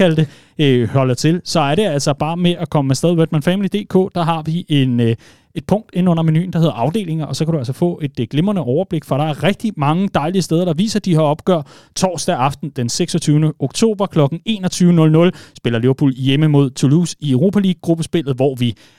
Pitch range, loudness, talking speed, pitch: 140-180 Hz, -16 LUFS, 200 wpm, 160 Hz